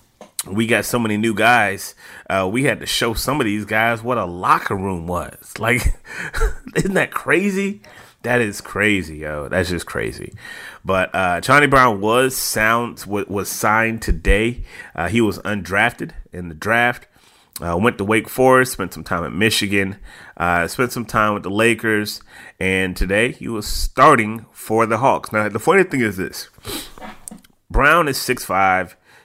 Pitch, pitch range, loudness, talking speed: 105 Hz, 95-115 Hz, -18 LUFS, 165 wpm